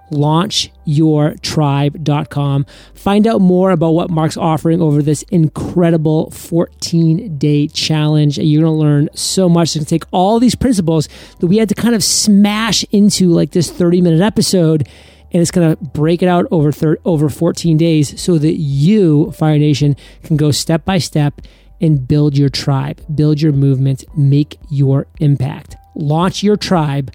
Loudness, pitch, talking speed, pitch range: -13 LUFS, 160 Hz, 170 wpm, 150-175 Hz